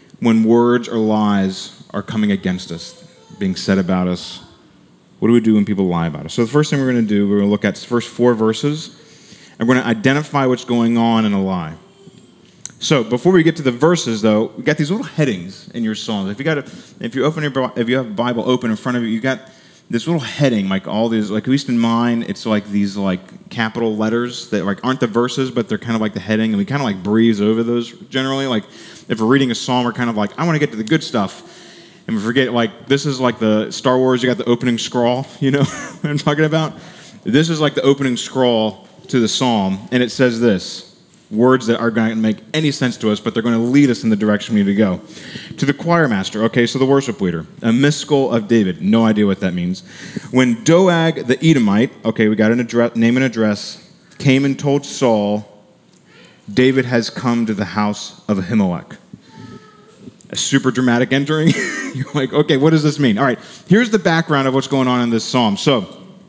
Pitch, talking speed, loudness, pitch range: 120 Hz, 235 wpm, -17 LUFS, 110-140 Hz